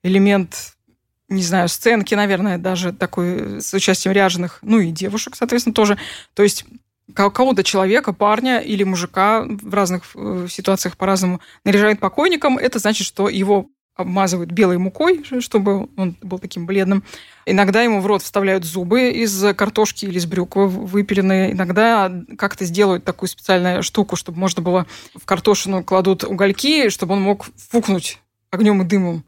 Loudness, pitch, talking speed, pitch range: -17 LUFS, 195 Hz, 150 wpm, 185-210 Hz